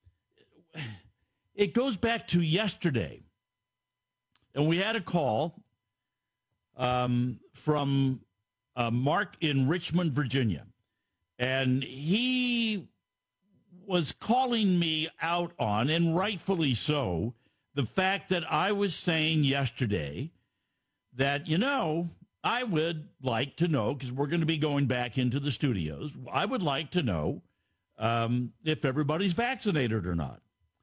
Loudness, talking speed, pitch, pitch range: -29 LUFS, 125 wpm, 140 Hz, 120-175 Hz